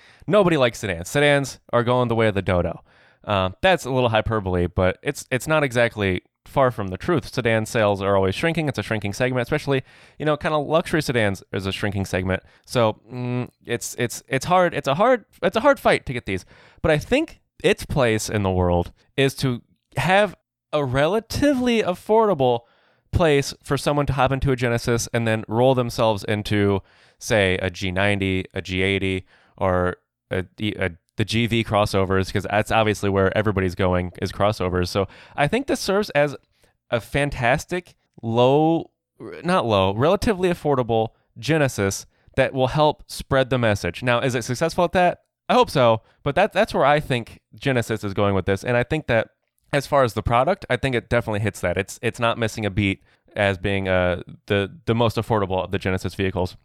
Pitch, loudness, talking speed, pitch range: 115 Hz, -22 LUFS, 190 wpm, 100-140 Hz